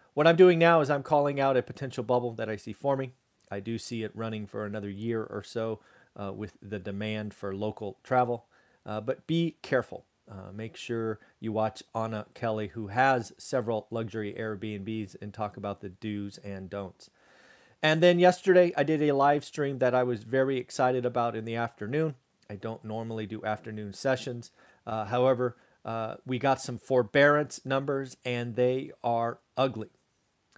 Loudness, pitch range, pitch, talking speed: -29 LUFS, 105-130 Hz, 115 Hz, 175 wpm